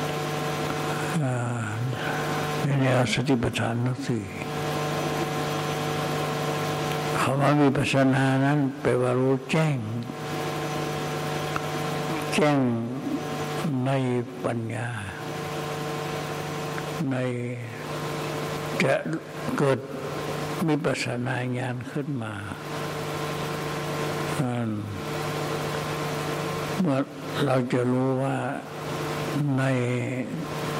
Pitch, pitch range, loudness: 150 Hz, 130-150 Hz, -27 LUFS